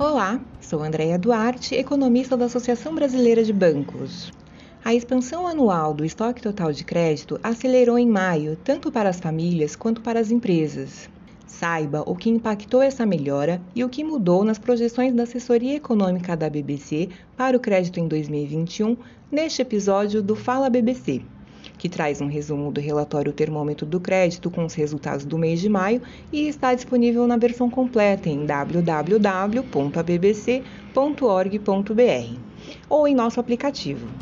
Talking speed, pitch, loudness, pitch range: 145 wpm, 205 Hz, -22 LUFS, 155-245 Hz